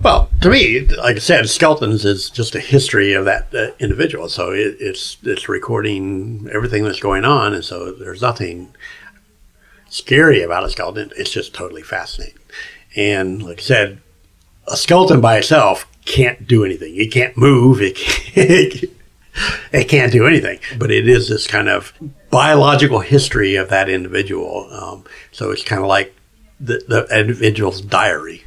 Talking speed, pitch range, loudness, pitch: 160 wpm, 100-140 Hz, -14 LUFS, 110 Hz